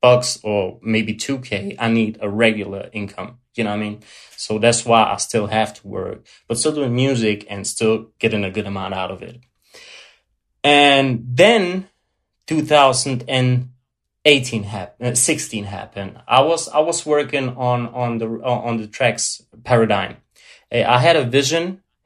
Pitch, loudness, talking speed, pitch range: 120 Hz, -18 LUFS, 155 wpm, 110-135 Hz